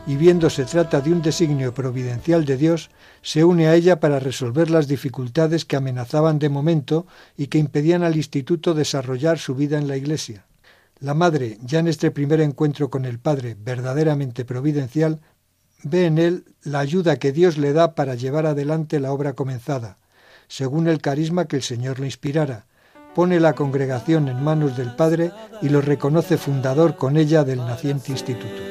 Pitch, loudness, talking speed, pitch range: 150 Hz, -20 LUFS, 175 wpm, 135-160 Hz